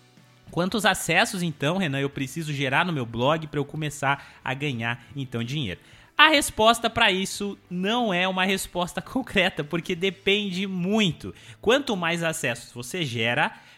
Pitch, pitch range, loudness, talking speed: 170 Hz, 140-195 Hz, -24 LUFS, 150 wpm